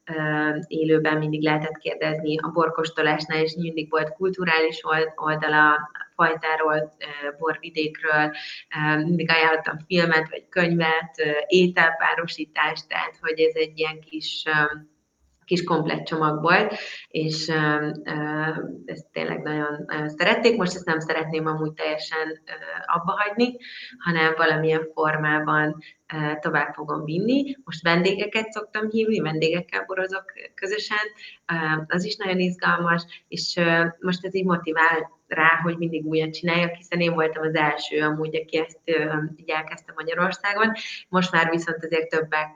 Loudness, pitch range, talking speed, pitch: -23 LUFS, 155-175 Hz, 120 wpm, 160 Hz